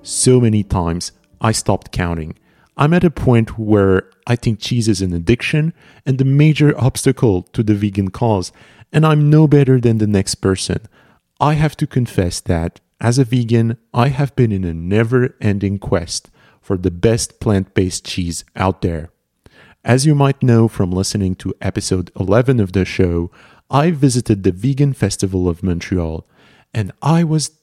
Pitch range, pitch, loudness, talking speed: 95-130 Hz, 110 Hz, -16 LUFS, 170 wpm